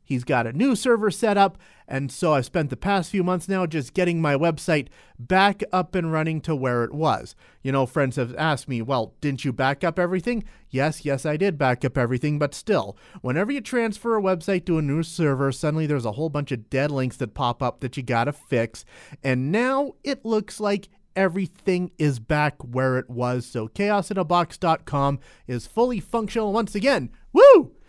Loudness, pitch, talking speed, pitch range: -23 LUFS, 155 Hz, 200 wpm, 135-195 Hz